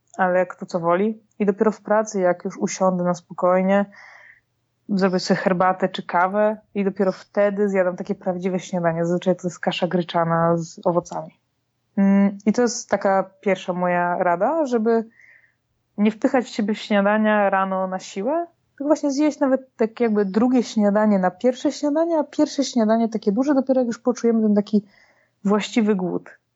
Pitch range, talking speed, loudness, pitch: 185-230 Hz, 165 wpm, -21 LUFS, 205 Hz